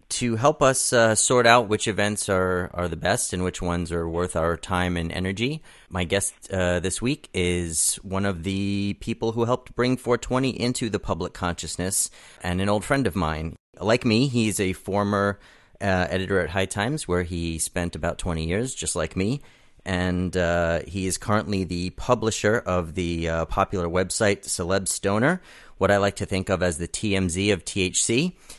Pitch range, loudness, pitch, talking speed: 90-110 Hz, -24 LUFS, 95 Hz, 185 wpm